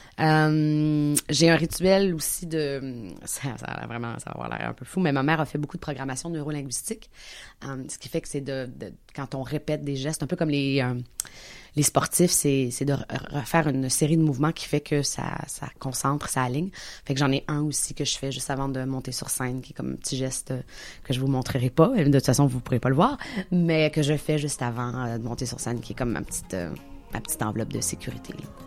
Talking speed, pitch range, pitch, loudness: 250 wpm, 130-155 Hz, 140 Hz, -26 LUFS